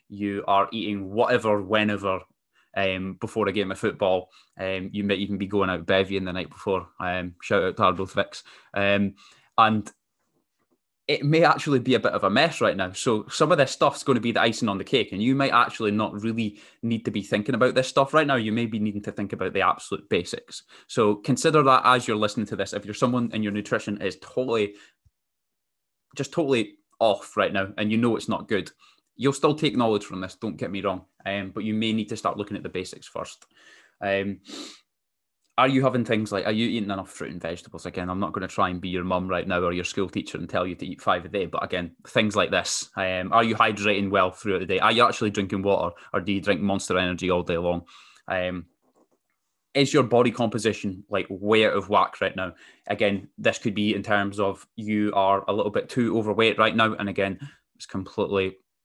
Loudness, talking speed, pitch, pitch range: -24 LUFS, 225 wpm, 105 Hz, 95-115 Hz